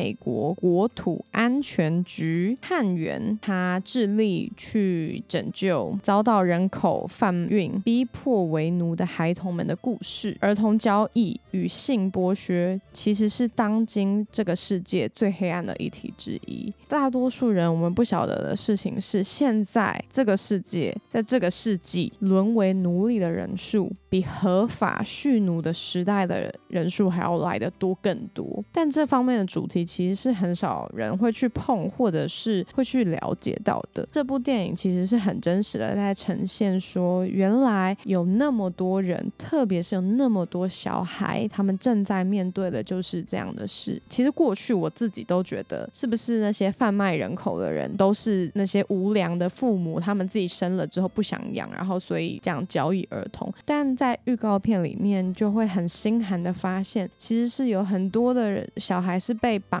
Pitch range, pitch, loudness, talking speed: 185-225 Hz, 200 Hz, -25 LUFS, 255 characters per minute